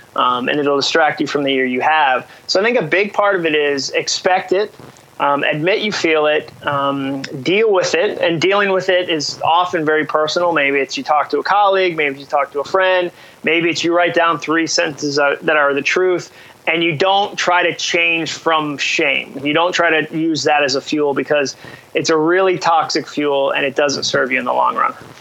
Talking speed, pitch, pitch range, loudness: 225 wpm, 160 Hz, 145-175 Hz, -16 LUFS